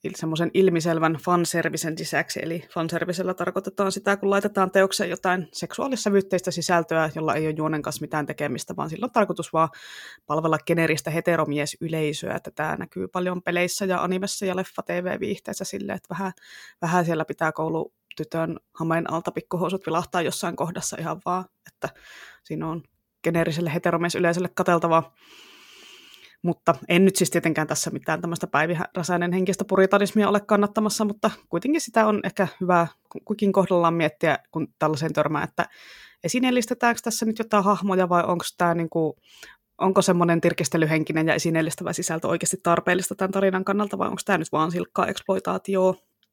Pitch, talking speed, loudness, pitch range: 175 Hz, 150 wpm, -24 LUFS, 165-195 Hz